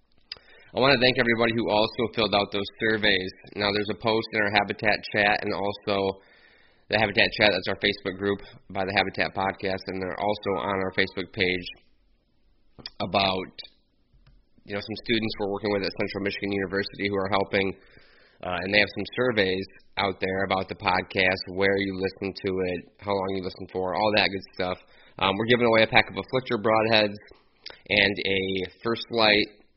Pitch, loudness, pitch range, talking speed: 100 Hz, -25 LUFS, 95-105 Hz, 180 wpm